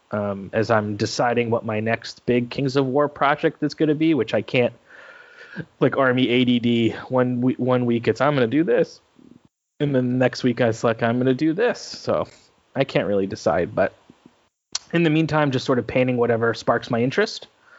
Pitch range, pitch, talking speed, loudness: 115-145 Hz, 125 Hz, 200 wpm, -21 LUFS